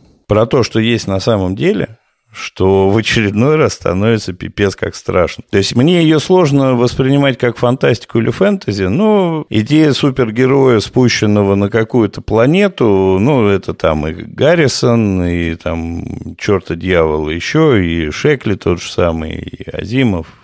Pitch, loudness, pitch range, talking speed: 110 Hz, -13 LUFS, 95-135 Hz, 145 wpm